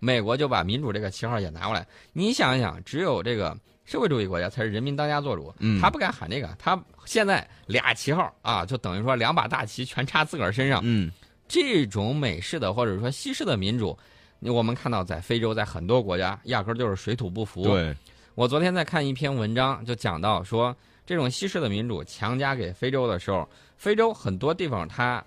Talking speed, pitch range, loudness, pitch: 320 characters per minute, 100-135 Hz, -26 LUFS, 120 Hz